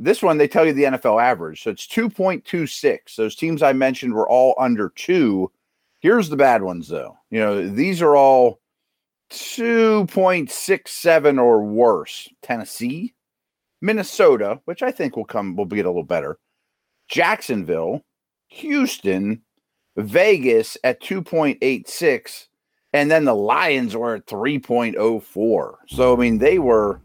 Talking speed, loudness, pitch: 135 wpm, -19 LUFS, 155 Hz